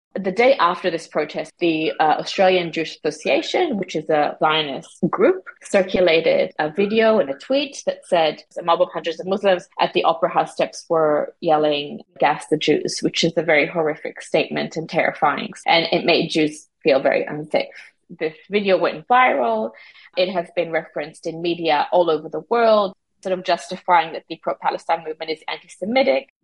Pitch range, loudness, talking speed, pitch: 160-190 Hz, -20 LUFS, 180 wpm, 170 Hz